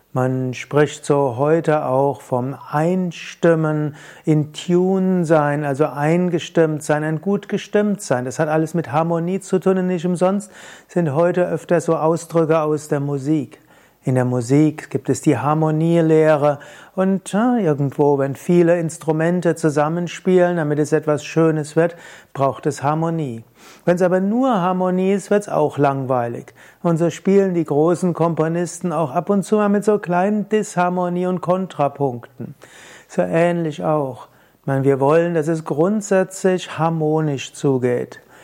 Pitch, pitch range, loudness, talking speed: 160 Hz, 145-180 Hz, -19 LUFS, 150 wpm